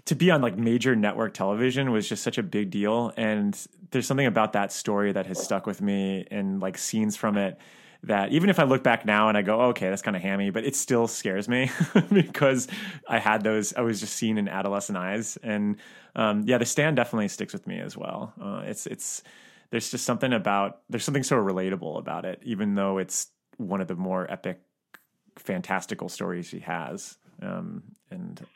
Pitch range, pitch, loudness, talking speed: 100-135 Hz, 110 Hz, -26 LUFS, 210 wpm